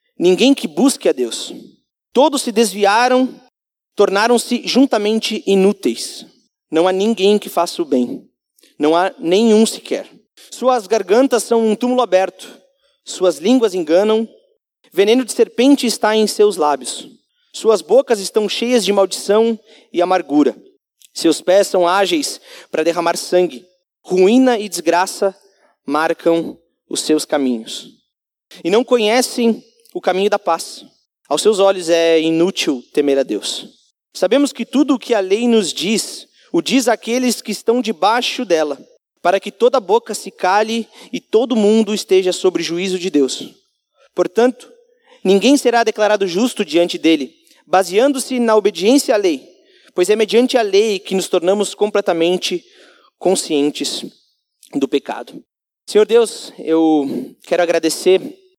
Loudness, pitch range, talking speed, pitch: -16 LUFS, 180-245 Hz, 135 wpm, 210 Hz